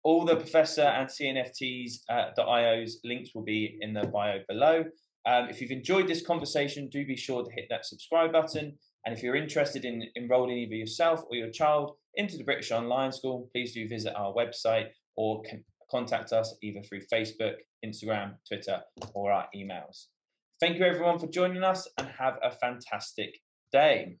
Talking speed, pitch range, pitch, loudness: 175 wpm, 110-150 Hz, 125 Hz, -30 LUFS